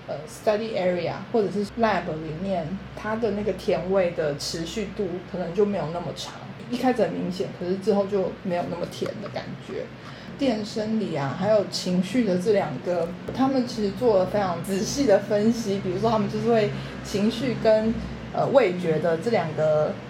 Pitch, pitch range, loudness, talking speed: 195 Hz, 175-220 Hz, -25 LUFS, 290 characters per minute